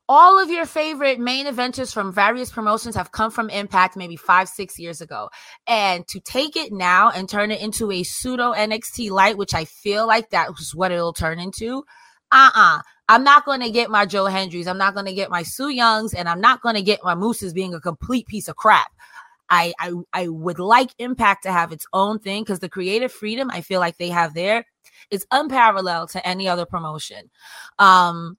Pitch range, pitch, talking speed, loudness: 180-235 Hz, 200 Hz, 205 wpm, -18 LUFS